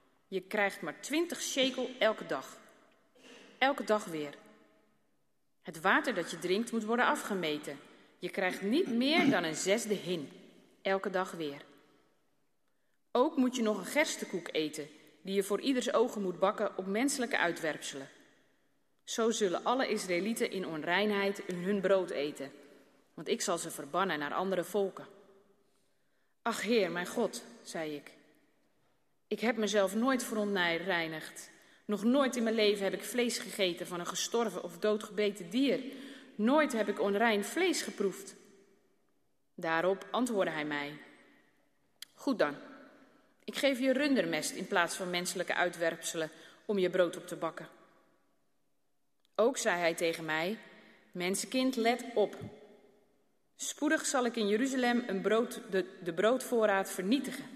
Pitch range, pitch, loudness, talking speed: 175-235 Hz, 200 Hz, -33 LUFS, 140 wpm